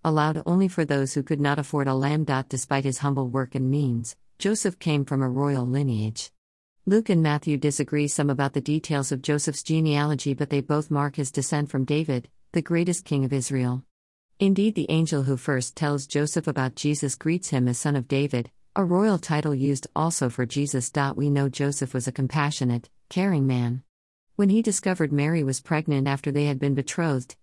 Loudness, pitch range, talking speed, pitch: -25 LUFS, 135-155 Hz, 190 wpm, 145 Hz